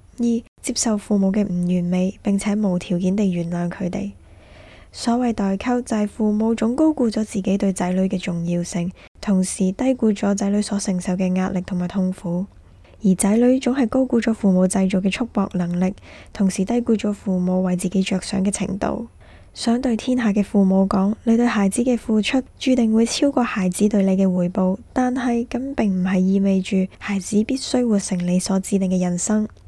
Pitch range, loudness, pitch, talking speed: 185-230 Hz, -20 LUFS, 200 Hz, 280 characters per minute